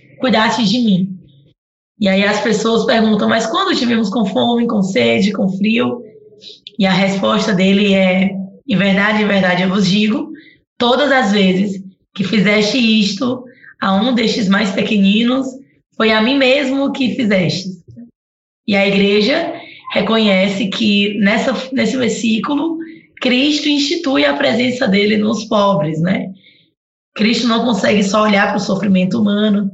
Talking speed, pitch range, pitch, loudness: 145 wpm, 195-245 Hz, 215 Hz, -14 LUFS